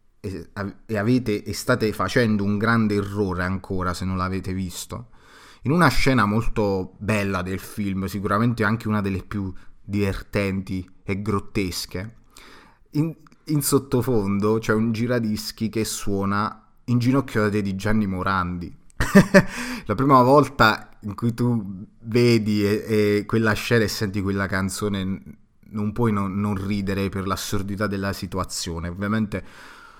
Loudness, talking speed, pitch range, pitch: -23 LUFS, 135 wpm, 95-115 Hz, 105 Hz